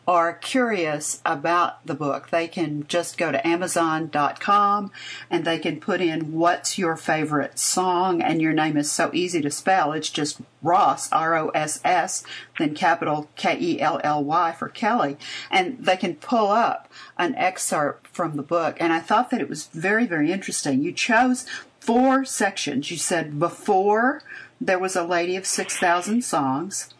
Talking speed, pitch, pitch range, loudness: 170 wpm, 175 Hz, 160-205 Hz, -22 LUFS